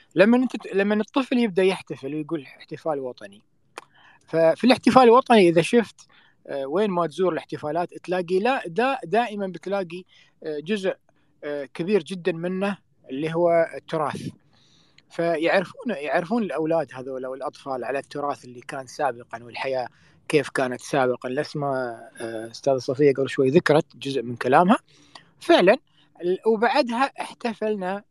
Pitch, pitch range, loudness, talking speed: 165 Hz, 135-200 Hz, -23 LUFS, 120 wpm